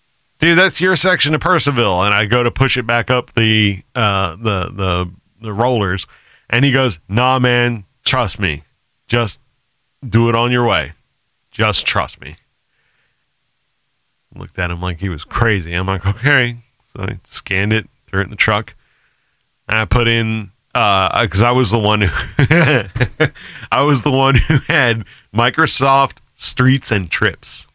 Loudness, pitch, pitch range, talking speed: -14 LUFS, 120 Hz, 105-135 Hz, 165 wpm